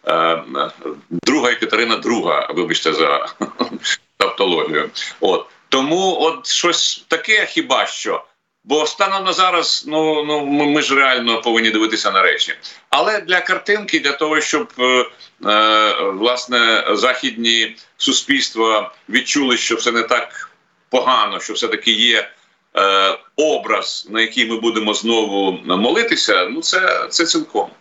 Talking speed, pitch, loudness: 125 wpm, 150 Hz, -16 LUFS